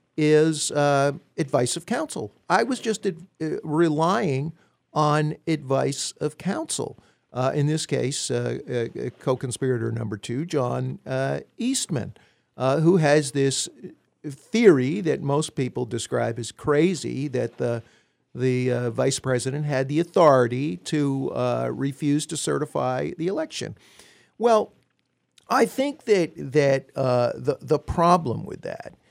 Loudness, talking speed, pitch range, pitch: -24 LUFS, 135 wpm, 130-165 Hz, 145 Hz